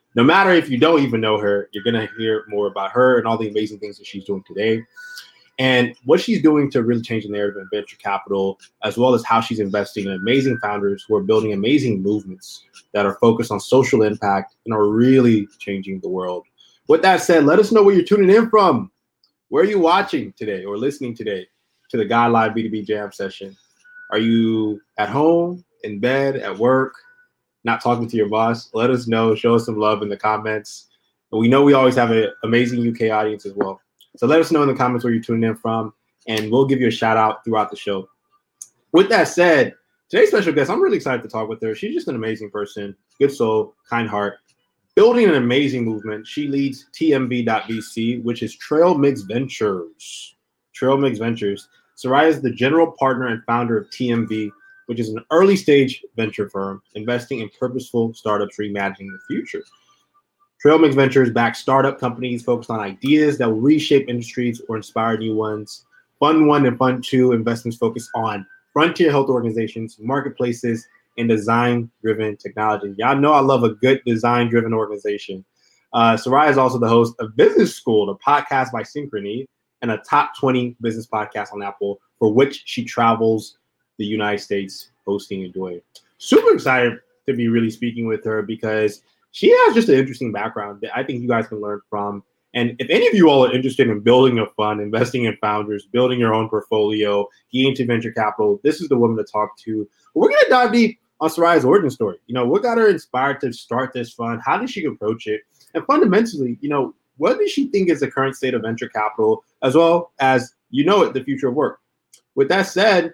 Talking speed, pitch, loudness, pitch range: 200 wpm, 120 Hz, -18 LUFS, 110-135 Hz